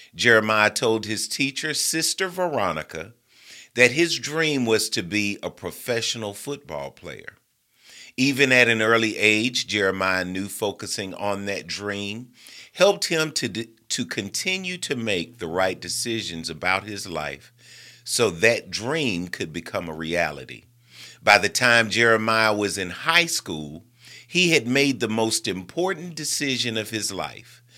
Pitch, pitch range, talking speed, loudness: 115 Hz, 100-135 Hz, 140 wpm, -22 LUFS